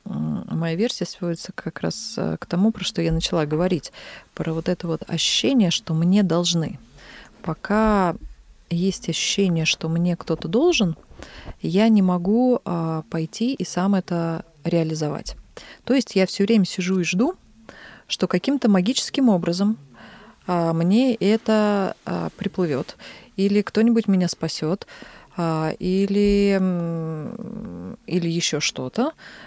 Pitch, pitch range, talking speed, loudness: 185 Hz, 165-215 Hz, 125 wpm, -22 LUFS